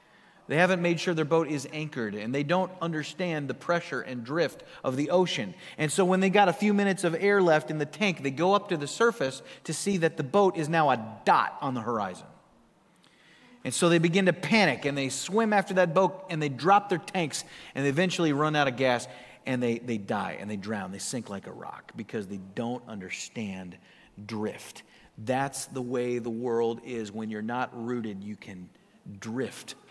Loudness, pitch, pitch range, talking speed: -28 LUFS, 150 Hz, 125-180 Hz, 210 wpm